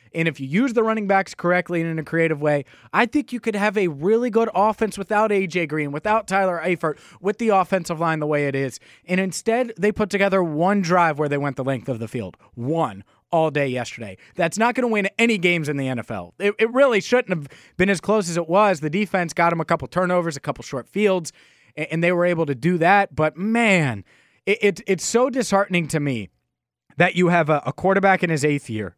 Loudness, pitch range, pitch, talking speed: -21 LUFS, 150-200 Hz, 175 Hz, 235 wpm